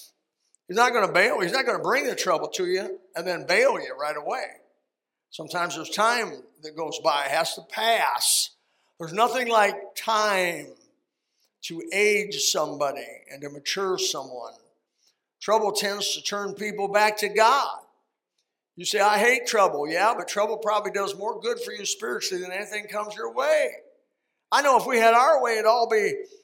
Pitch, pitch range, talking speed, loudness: 210 Hz, 195-245 Hz, 180 wpm, -24 LUFS